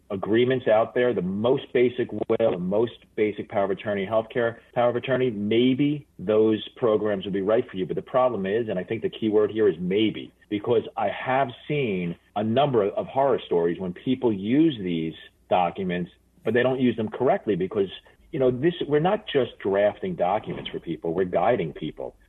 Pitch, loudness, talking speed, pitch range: 110 Hz, -25 LUFS, 195 wpm, 100-125 Hz